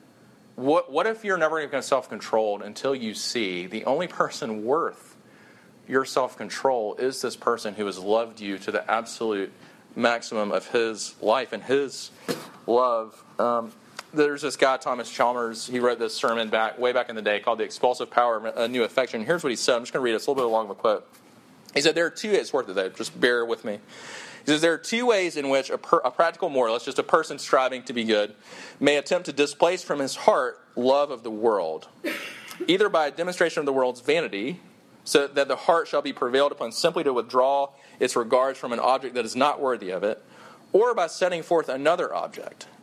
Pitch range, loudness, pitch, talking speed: 115-155 Hz, -25 LUFS, 135 Hz, 215 wpm